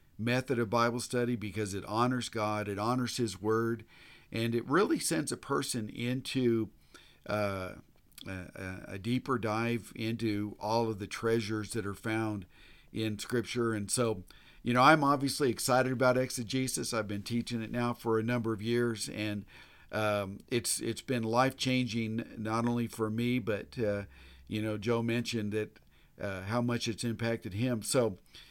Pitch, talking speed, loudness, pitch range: 115 Hz, 165 wpm, -32 LUFS, 105-120 Hz